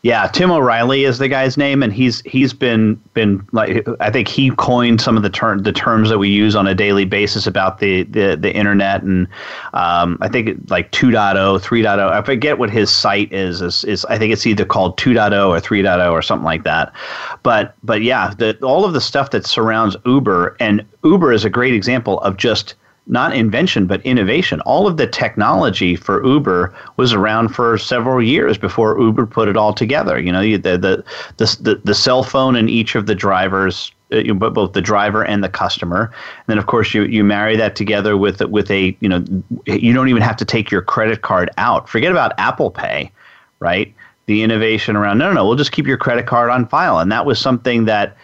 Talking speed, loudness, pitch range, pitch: 215 wpm, -14 LUFS, 100-120 Hz, 110 Hz